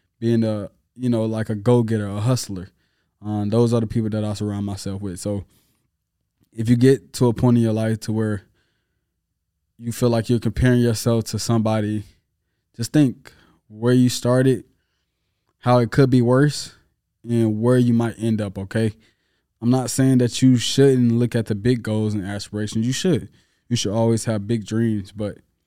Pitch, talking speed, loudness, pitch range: 110 Hz, 185 wpm, -20 LUFS, 105-120 Hz